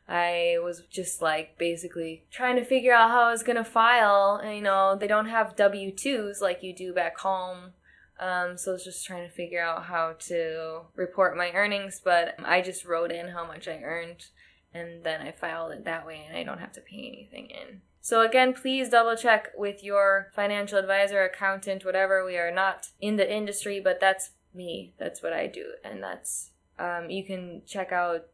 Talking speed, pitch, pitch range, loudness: 200 wpm, 190 Hz, 175-205 Hz, -26 LUFS